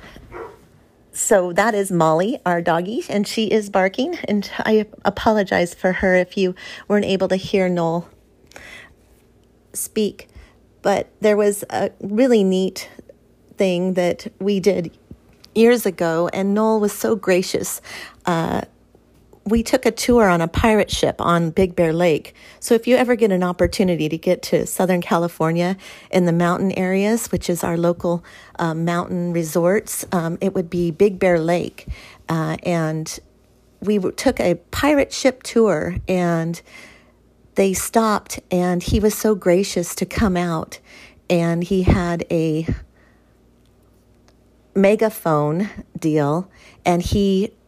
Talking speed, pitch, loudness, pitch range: 140 wpm, 185 Hz, -19 LUFS, 175-210 Hz